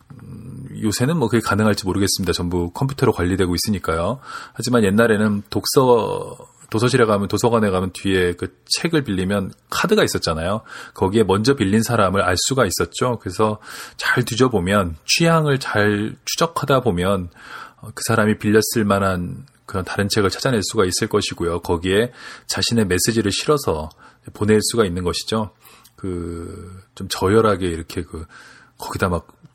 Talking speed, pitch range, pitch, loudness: 335 characters per minute, 95-115 Hz, 105 Hz, -19 LUFS